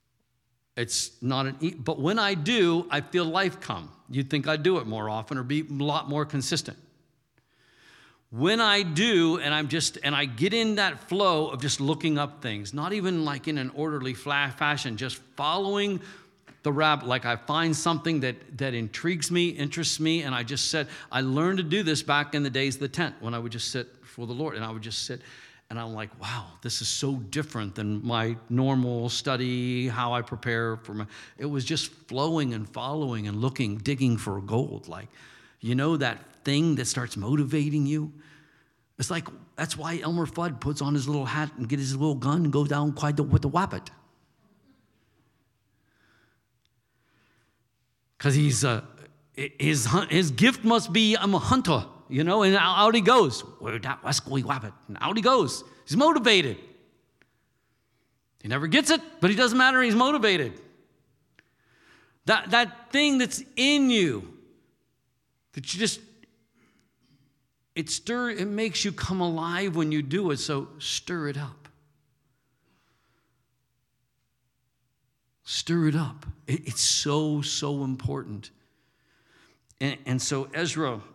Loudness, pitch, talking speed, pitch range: -26 LUFS, 145 Hz, 165 wpm, 125-165 Hz